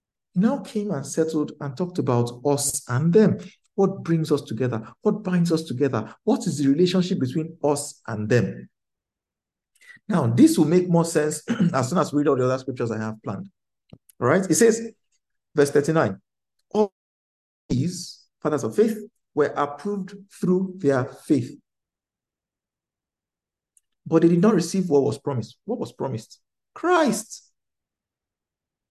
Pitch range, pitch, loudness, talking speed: 135-195 Hz, 160 Hz, -23 LUFS, 150 wpm